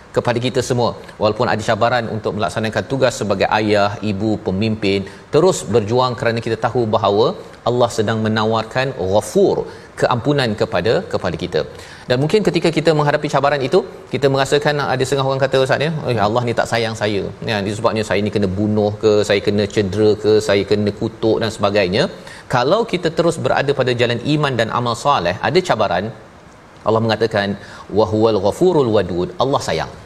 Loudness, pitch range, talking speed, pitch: -17 LUFS, 105-135 Hz, 165 wpm, 115 Hz